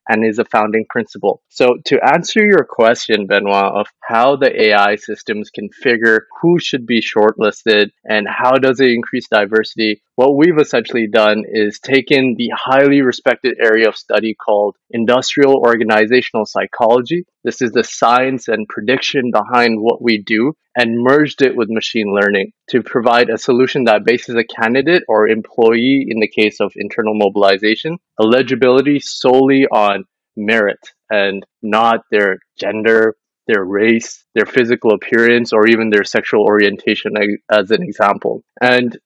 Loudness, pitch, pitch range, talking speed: -13 LUFS, 115 Hz, 105-125 Hz, 150 wpm